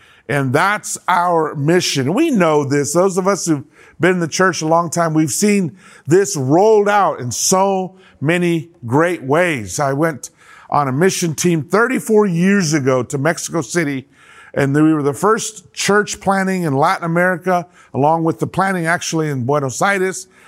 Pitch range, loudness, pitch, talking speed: 150-190 Hz, -16 LUFS, 170 Hz, 170 wpm